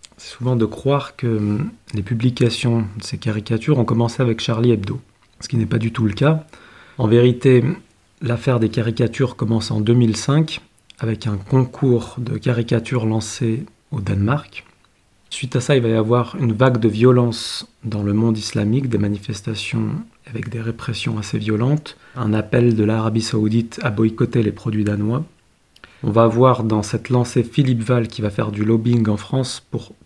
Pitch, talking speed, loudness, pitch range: 115 Hz, 175 wpm, -19 LUFS, 110-125 Hz